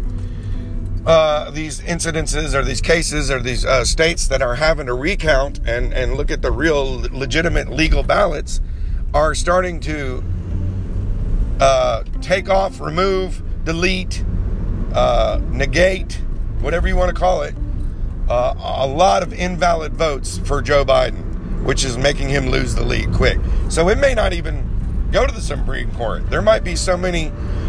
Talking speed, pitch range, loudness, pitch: 155 wpm, 95-155 Hz, -19 LUFS, 130 Hz